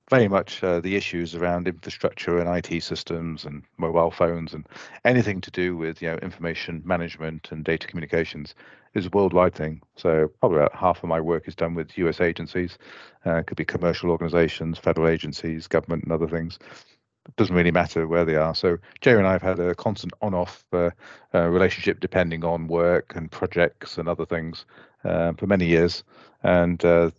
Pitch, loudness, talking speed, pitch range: 85 Hz, -24 LUFS, 190 wpm, 80-90 Hz